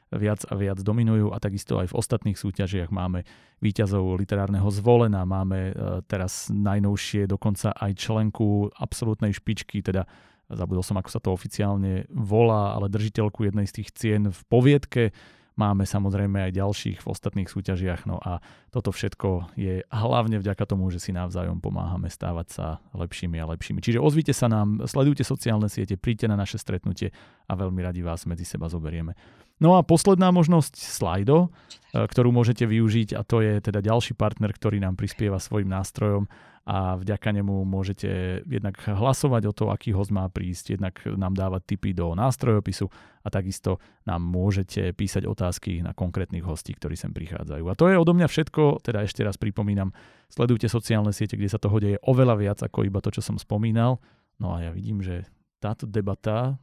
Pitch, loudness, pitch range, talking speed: 100 Hz, -25 LUFS, 95-110 Hz, 170 wpm